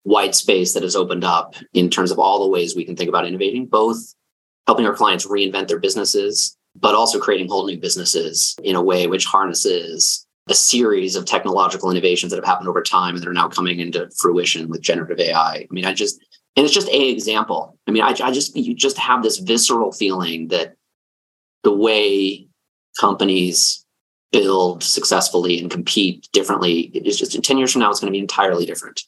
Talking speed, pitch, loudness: 200 wpm, 110 Hz, -17 LUFS